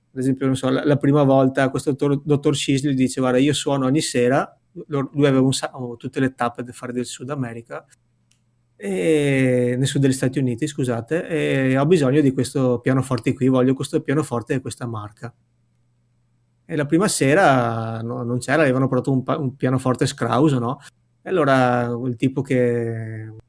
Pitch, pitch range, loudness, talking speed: 130 Hz, 120-140 Hz, -20 LUFS, 180 wpm